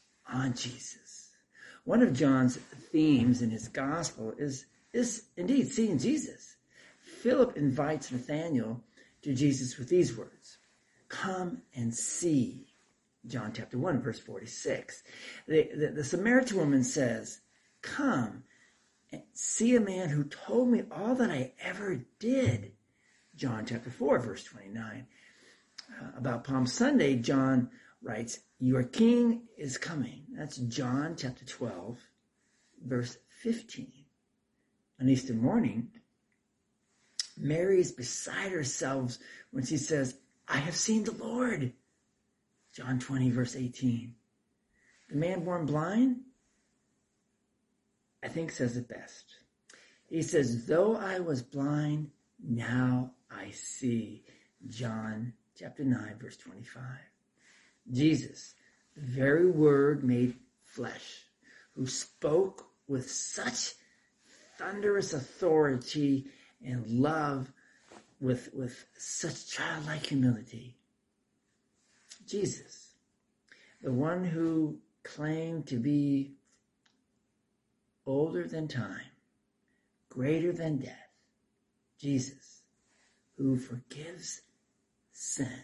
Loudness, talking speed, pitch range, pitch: -32 LUFS, 105 wpm, 125-175 Hz, 140 Hz